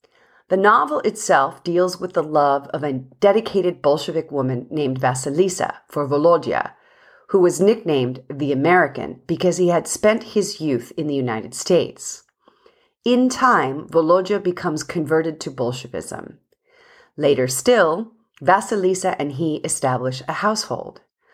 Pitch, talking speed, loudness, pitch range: 175 Hz, 130 wpm, -20 LUFS, 145-210 Hz